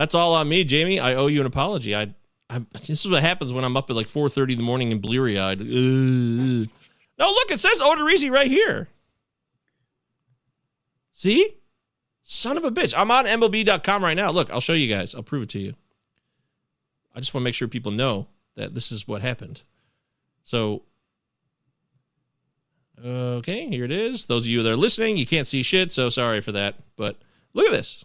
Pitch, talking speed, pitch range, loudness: 130 Hz, 195 wpm, 120-165 Hz, -21 LUFS